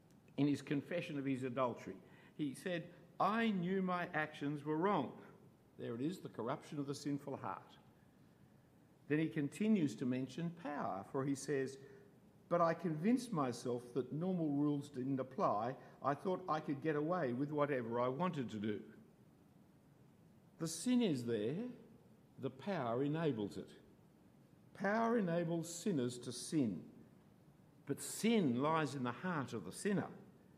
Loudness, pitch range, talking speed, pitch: -40 LUFS, 135-175 Hz, 145 wpm, 150 Hz